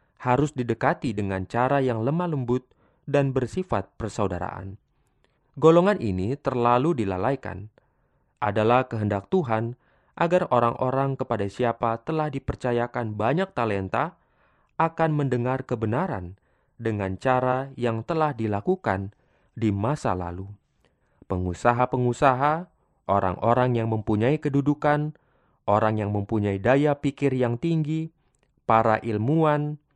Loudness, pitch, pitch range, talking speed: -25 LUFS, 125 Hz, 110-145 Hz, 100 wpm